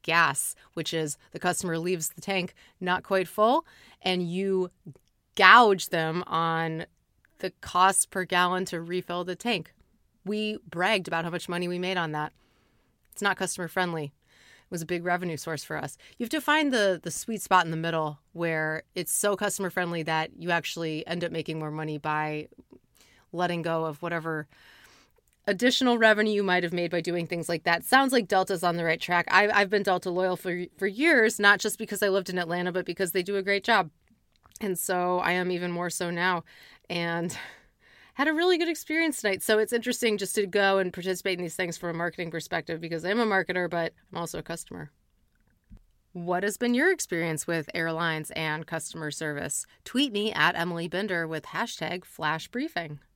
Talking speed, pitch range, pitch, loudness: 195 wpm, 165-200 Hz, 180 Hz, -27 LUFS